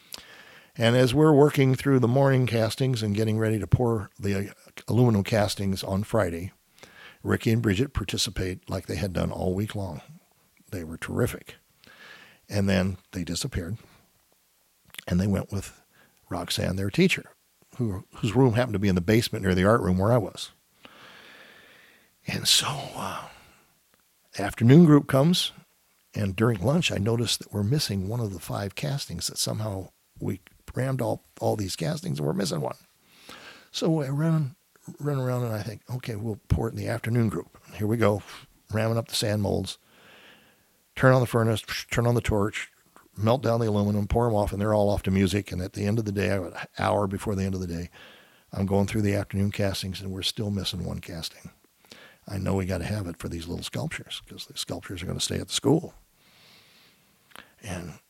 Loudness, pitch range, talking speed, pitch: -26 LUFS, 95-120 Hz, 190 wpm, 105 Hz